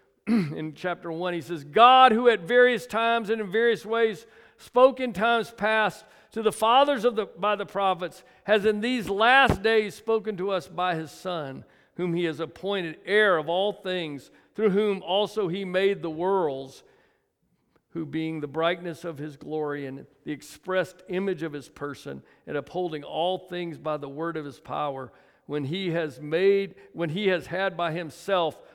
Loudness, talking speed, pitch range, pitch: -25 LUFS, 180 wpm, 160-215 Hz, 185 Hz